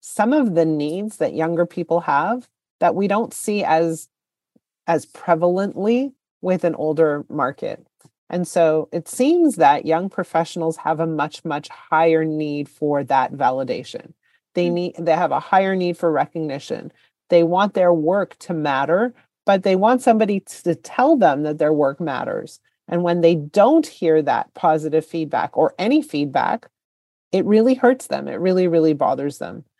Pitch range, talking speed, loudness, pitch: 160-195 Hz, 165 wpm, -19 LUFS, 170 Hz